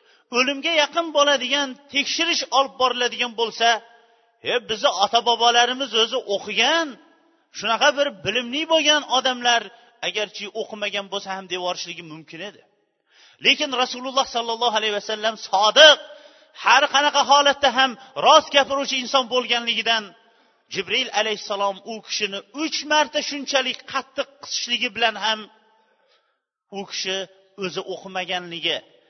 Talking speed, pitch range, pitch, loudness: 110 wpm, 215-280 Hz, 240 Hz, -20 LUFS